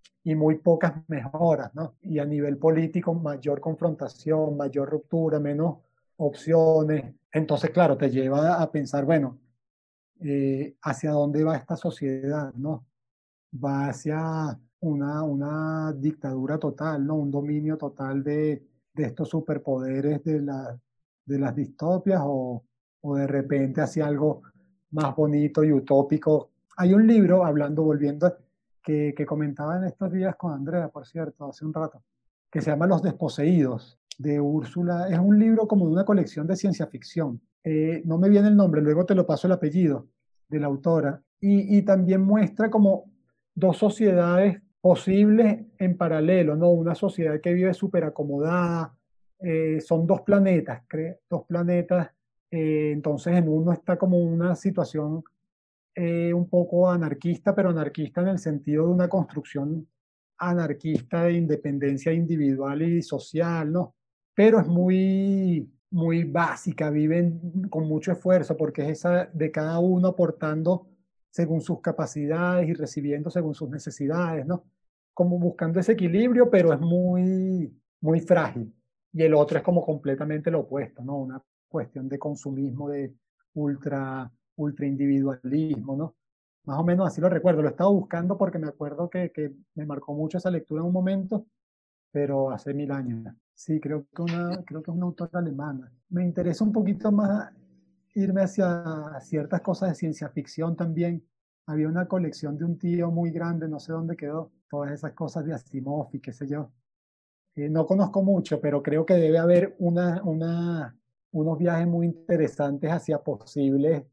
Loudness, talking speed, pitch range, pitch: -25 LUFS, 155 wpm, 145-175 Hz, 160 Hz